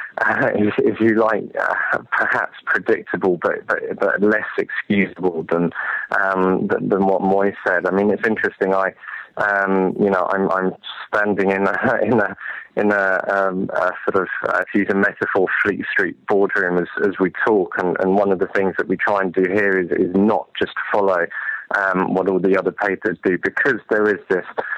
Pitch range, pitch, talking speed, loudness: 95-100 Hz, 95 Hz, 195 wpm, -19 LUFS